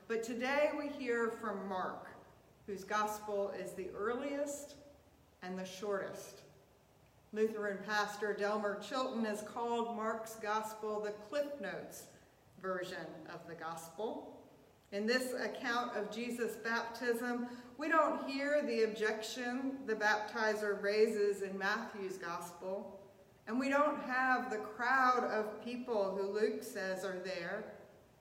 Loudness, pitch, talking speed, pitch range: -38 LUFS, 215 Hz, 125 wpm, 195-240 Hz